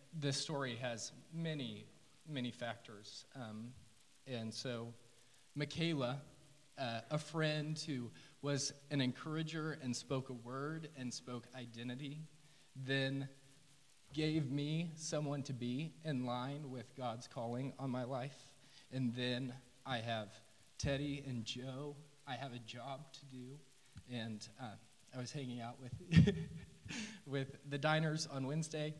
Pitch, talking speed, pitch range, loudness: 135 Hz, 130 wpm, 120-145 Hz, -42 LUFS